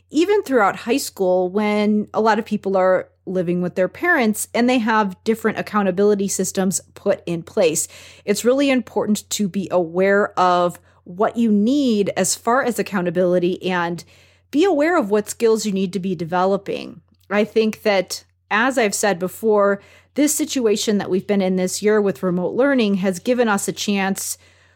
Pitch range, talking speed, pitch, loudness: 185-225 Hz, 170 wpm, 205 Hz, -19 LUFS